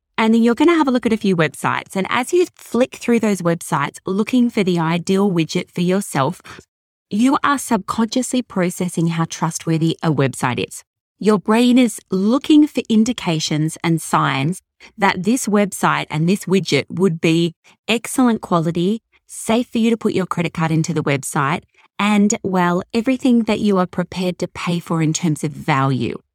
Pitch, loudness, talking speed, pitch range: 185 Hz, -18 LUFS, 180 wpm, 165-230 Hz